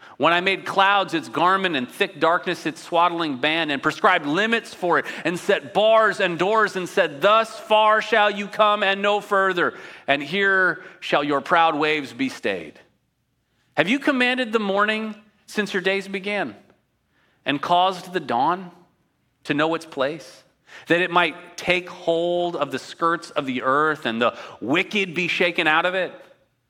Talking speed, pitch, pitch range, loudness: 170 wpm, 180 Hz, 160-205 Hz, -21 LUFS